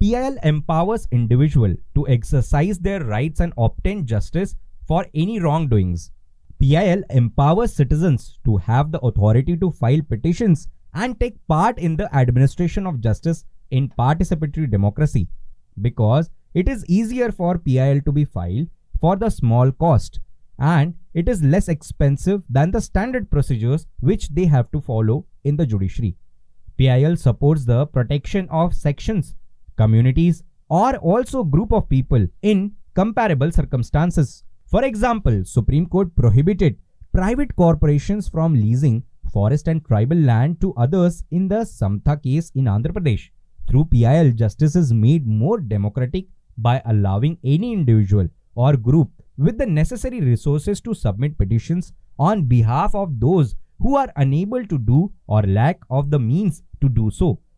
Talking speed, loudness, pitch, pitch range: 145 wpm, -19 LUFS, 145 Hz, 120-175 Hz